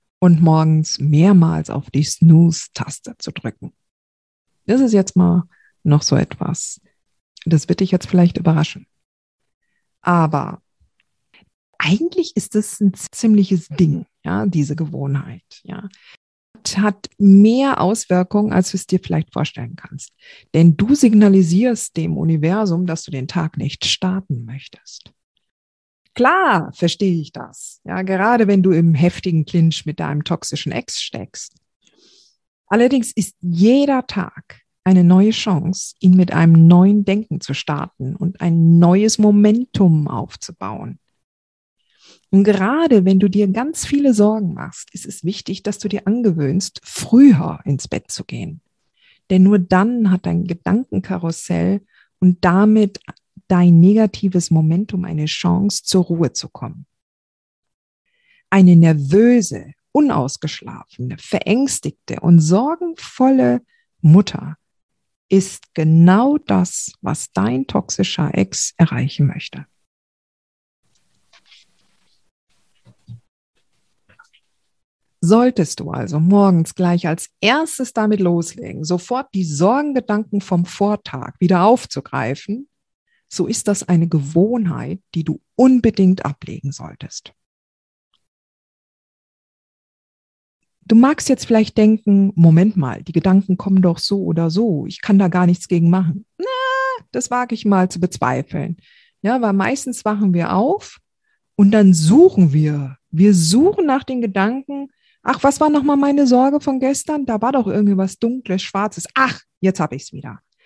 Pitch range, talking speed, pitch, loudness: 165-215 Hz, 125 wpm, 185 Hz, -16 LUFS